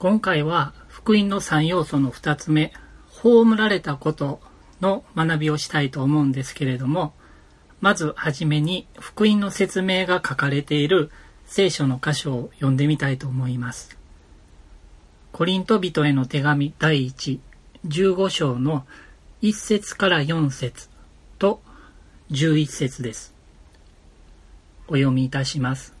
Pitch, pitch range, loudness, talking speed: 145 Hz, 125-175 Hz, -22 LUFS, 225 characters per minute